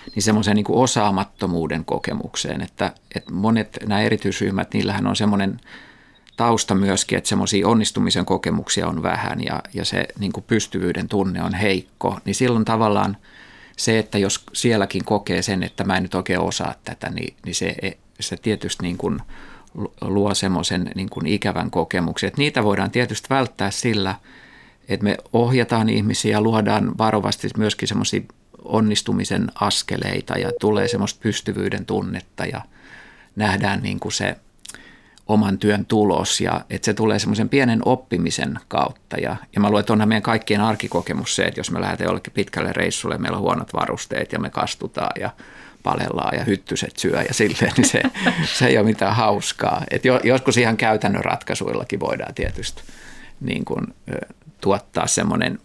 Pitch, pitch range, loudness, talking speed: 105 Hz, 100-110 Hz, -21 LUFS, 155 wpm